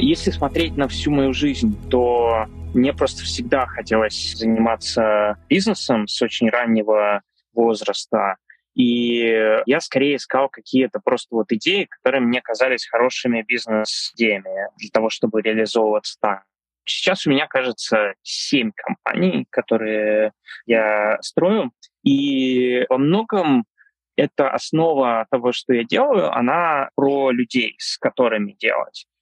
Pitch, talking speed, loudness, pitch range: 120 Hz, 120 wpm, -19 LUFS, 110-140 Hz